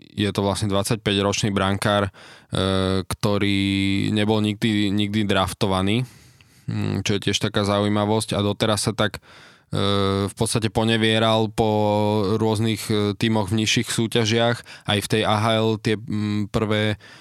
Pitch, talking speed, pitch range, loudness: 105 Hz, 120 wpm, 100-110 Hz, -21 LUFS